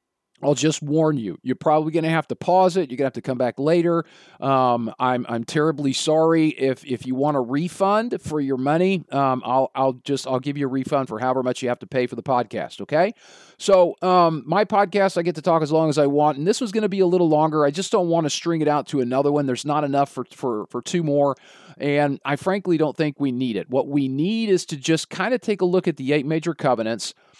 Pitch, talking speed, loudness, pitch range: 150 Hz, 260 wpm, -21 LUFS, 135-170 Hz